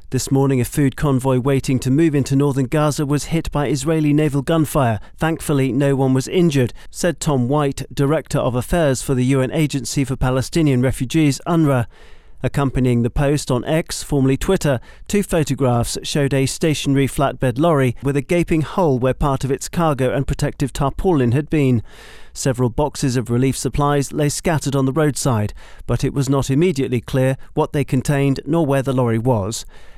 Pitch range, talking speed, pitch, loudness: 130-150 Hz, 175 wpm, 140 Hz, -18 LUFS